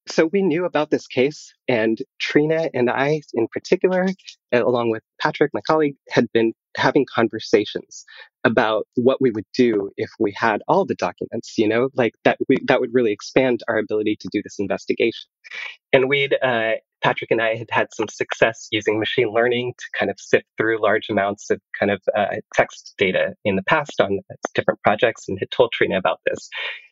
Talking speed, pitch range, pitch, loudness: 190 wpm, 115-150 Hz, 125 Hz, -21 LUFS